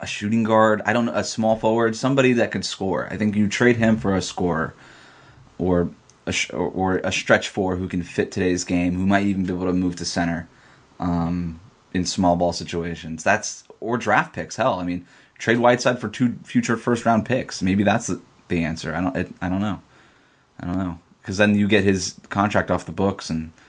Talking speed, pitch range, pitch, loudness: 215 wpm, 90-110 Hz, 95 Hz, -22 LUFS